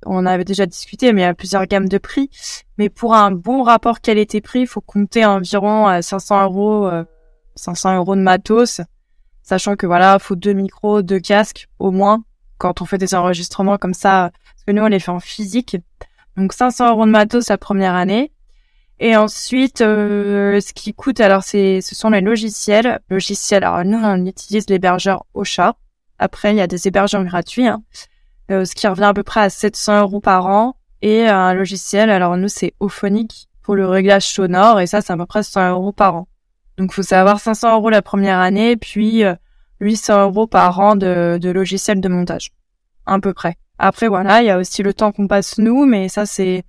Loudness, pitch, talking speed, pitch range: -15 LUFS, 200 Hz, 205 wpm, 190-215 Hz